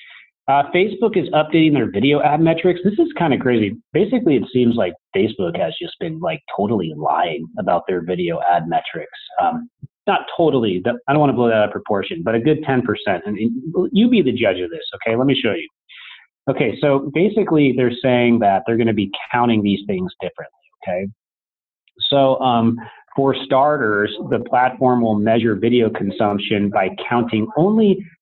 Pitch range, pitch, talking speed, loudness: 115-170 Hz, 130 Hz, 180 wpm, -18 LUFS